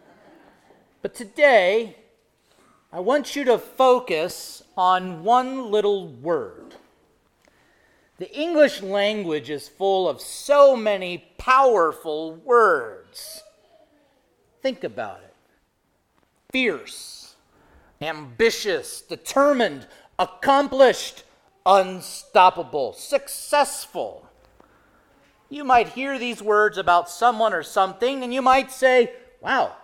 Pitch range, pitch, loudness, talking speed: 195-285 Hz, 255 Hz, -21 LUFS, 90 wpm